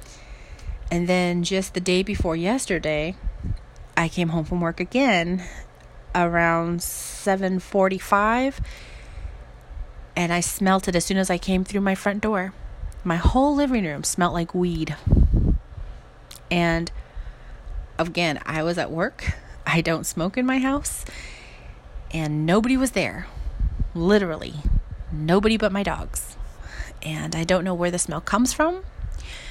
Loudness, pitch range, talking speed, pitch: -23 LUFS, 165-195 Hz, 130 wpm, 175 Hz